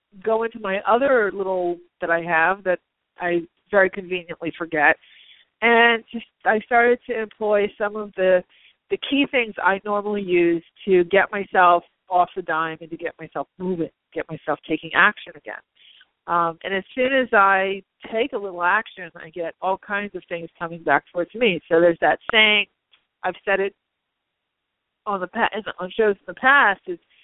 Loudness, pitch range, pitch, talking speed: -21 LUFS, 175-215 Hz, 190 Hz, 175 wpm